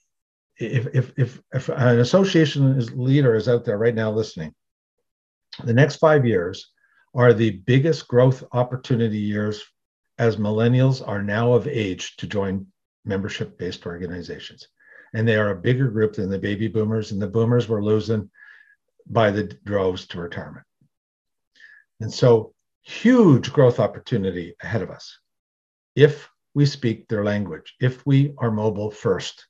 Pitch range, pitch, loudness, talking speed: 105-130 Hz, 115 Hz, -21 LUFS, 150 wpm